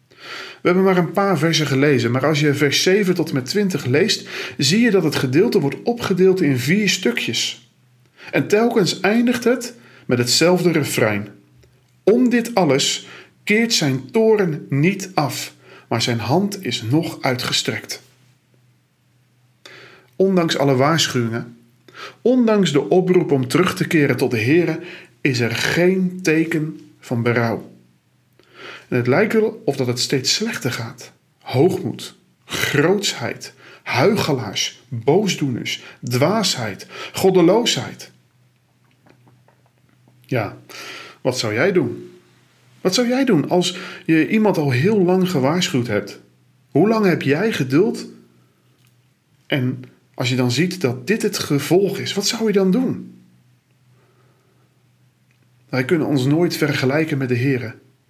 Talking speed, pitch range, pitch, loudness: 130 wpm, 125-180 Hz, 140 Hz, -18 LUFS